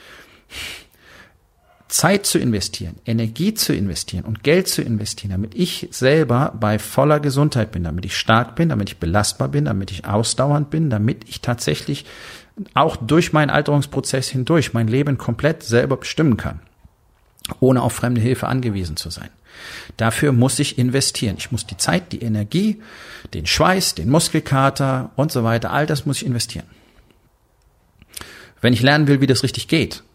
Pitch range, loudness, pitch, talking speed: 105-145 Hz, -19 LUFS, 120 Hz, 160 wpm